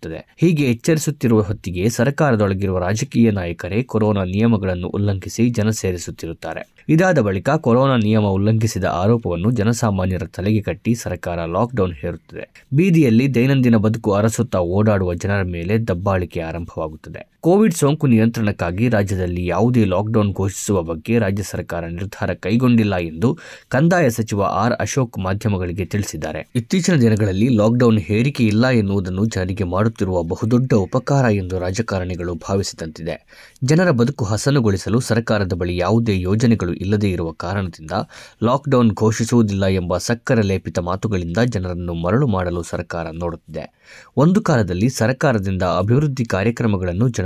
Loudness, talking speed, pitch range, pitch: -18 LUFS, 115 wpm, 90-120 Hz, 105 Hz